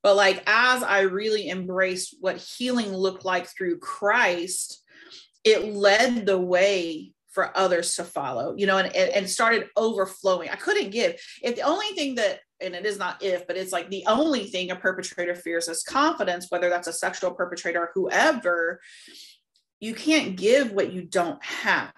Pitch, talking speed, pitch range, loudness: 190 Hz, 175 wpm, 180-225 Hz, -24 LUFS